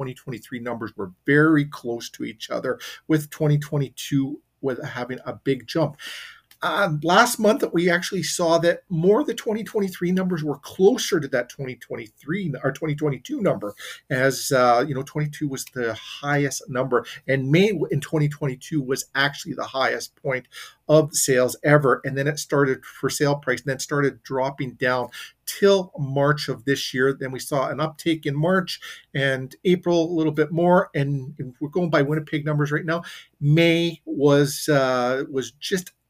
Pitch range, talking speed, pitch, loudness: 130-160 Hz, 165 wpm, 145 Hz, -23 LUFS